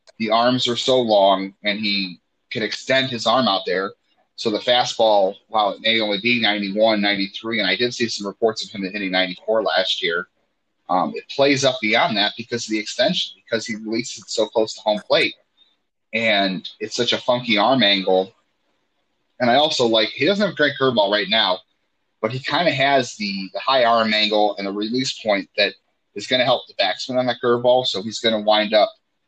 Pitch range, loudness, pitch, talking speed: 105-125 Hz, -19 LUFS, 110 Hz, 210 wpm